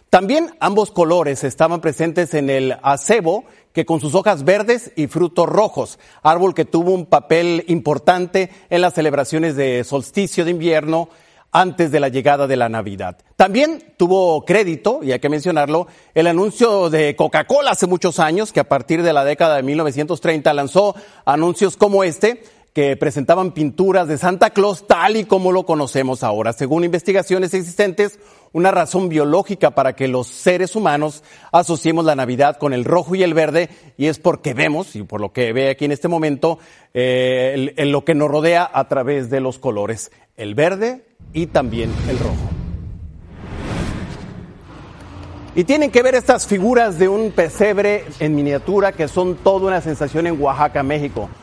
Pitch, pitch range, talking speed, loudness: 165 Hz, 140-185 Hz, 170 wpm, -17 LUFS